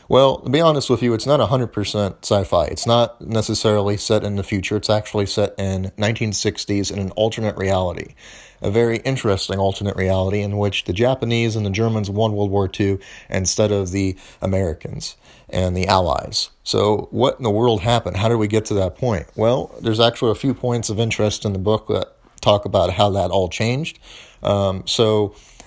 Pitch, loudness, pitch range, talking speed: 105 Hz, -19 LUFS, 95-115 Hz, 190 wpm